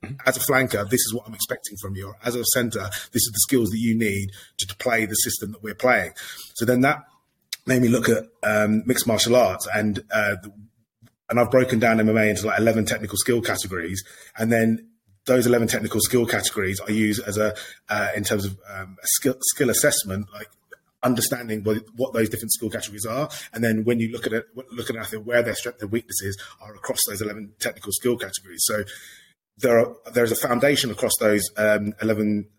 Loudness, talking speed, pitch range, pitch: -22 LUFS, 210 wpm, 105-120 Hz, 110 Hz